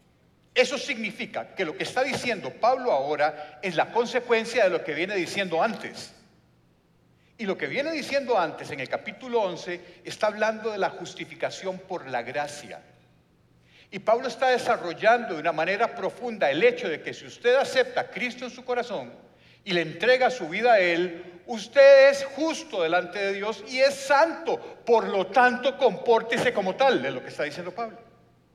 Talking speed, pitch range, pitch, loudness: 175 wpm, 175-255 Hz, 225 Hz, -25 LUFS